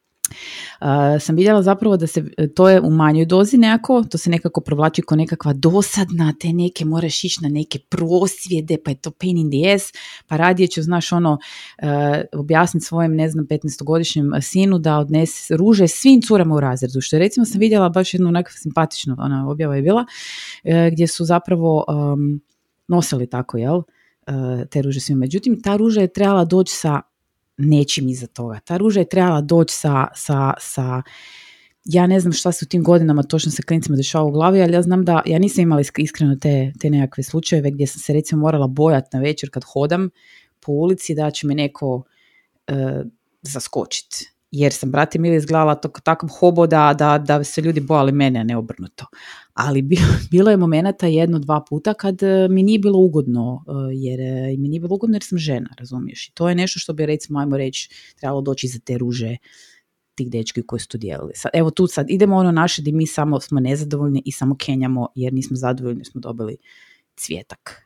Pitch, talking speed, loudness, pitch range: 155 Hz, 195 wpm, -17 LUFS, 140-175 Hz